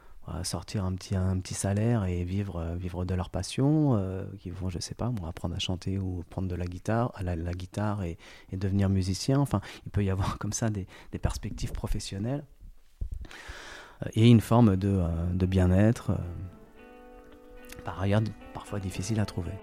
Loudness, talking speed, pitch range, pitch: -29 LUFS, 175 wpm, 90-105 Hz, 95 Hz